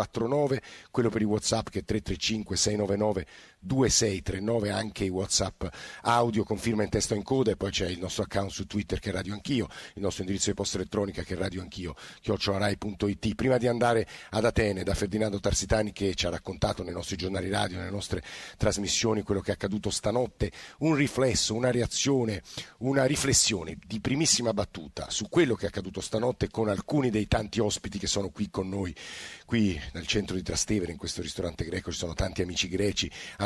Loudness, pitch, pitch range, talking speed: -29 LUFS, 100 Hz, 95-110 Hz, 190 wpm